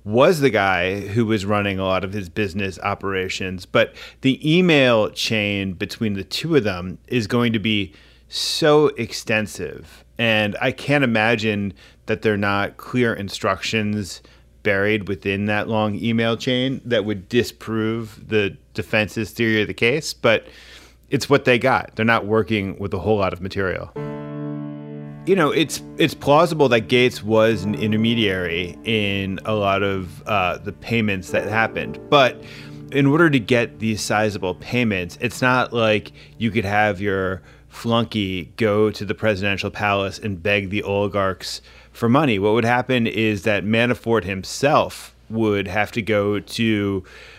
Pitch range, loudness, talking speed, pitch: 95-115 Hz, -20 LUFS, 155 wpm, 105 Hz